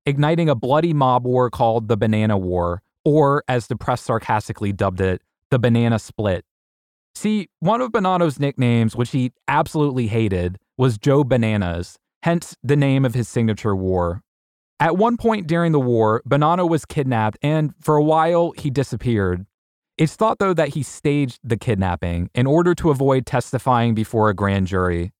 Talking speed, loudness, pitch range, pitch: 165 wpm, -19 LUFS, 105-150 Hz, 125 Hz